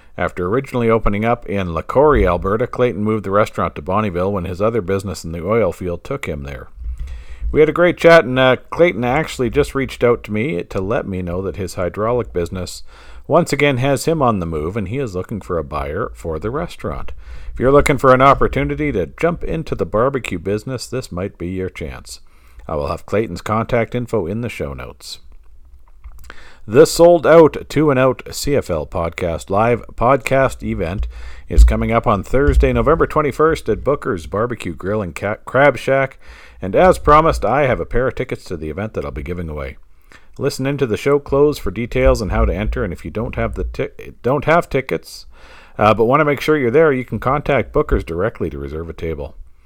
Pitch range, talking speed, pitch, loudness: 85-135 Hz, 205 wpm, 110 Hz, -17 LUFS